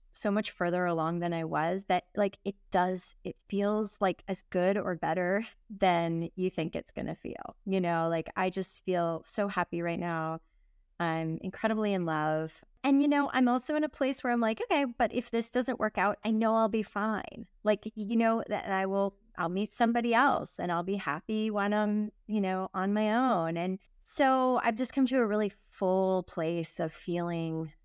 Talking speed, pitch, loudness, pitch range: 205 wpm, 200 Hz, -31 LUFS, 175-220 Hz